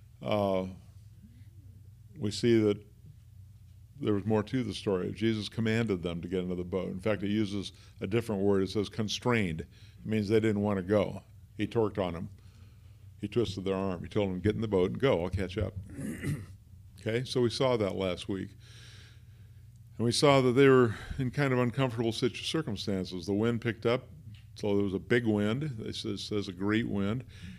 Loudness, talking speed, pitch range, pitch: -31 LUFS, 190 wpm, 100-115 Hz, 105 Hz